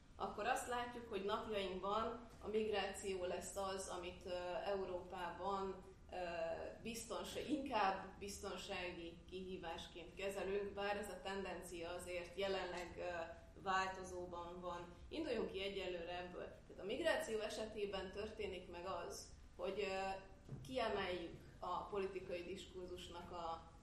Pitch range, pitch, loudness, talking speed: 175-200 Hz, 190 Hz, -46 LUFS, 100 wpm